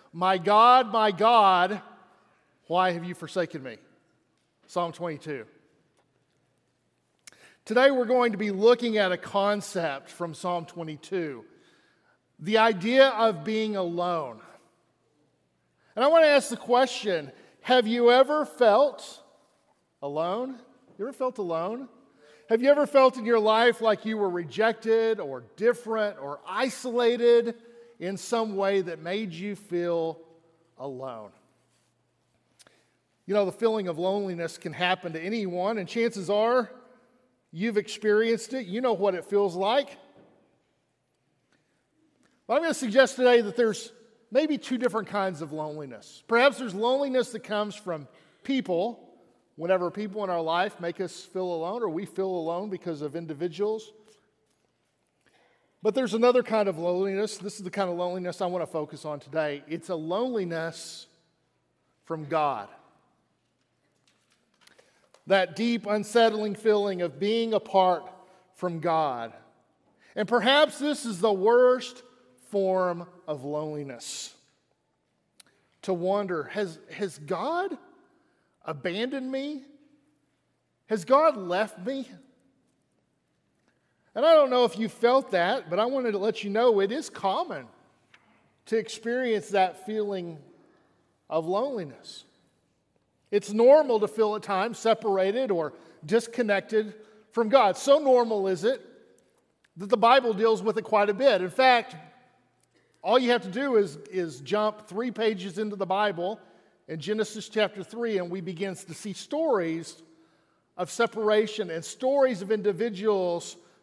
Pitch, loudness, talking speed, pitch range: 210 Hz, -26 LUFS, 135 wpm, 175-235 Hz